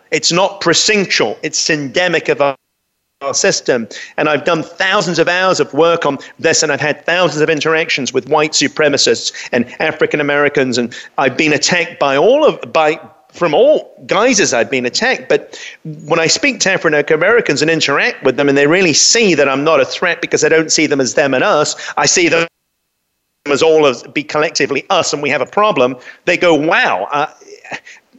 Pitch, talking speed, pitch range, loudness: 160 Hz, 195 wpm, 150-175 Hz, -13 LUFS